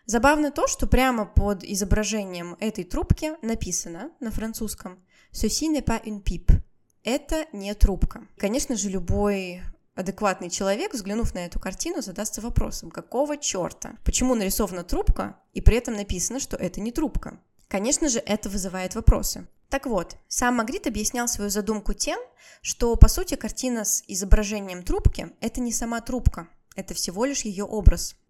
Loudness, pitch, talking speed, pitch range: -26 LUFS, 220 Hz, 155 wpm, 200-255 Hz